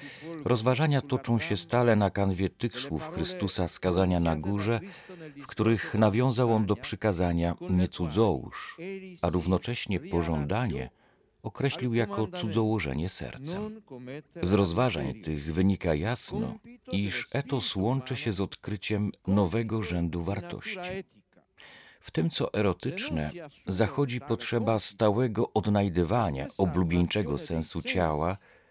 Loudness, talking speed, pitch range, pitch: -29 LUFS, 105 wpm, 90-125 Hz, 110 Hz